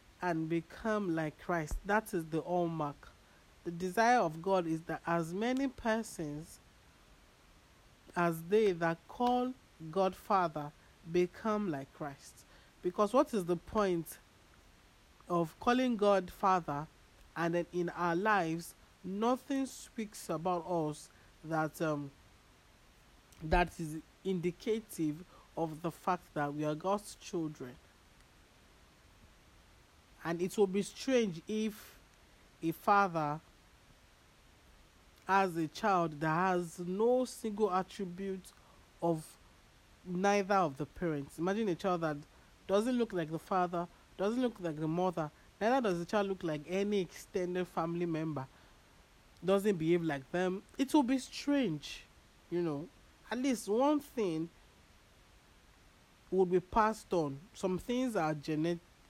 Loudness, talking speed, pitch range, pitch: -35 LUFS, 125 wpm, 160-205 Hz, 175 Hz